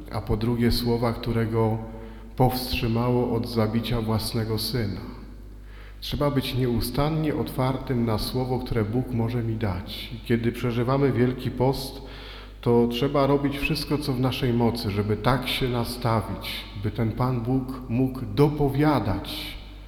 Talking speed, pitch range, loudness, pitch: 135 wpm, 115-130 Hz, -25 LUFS, 120 Hz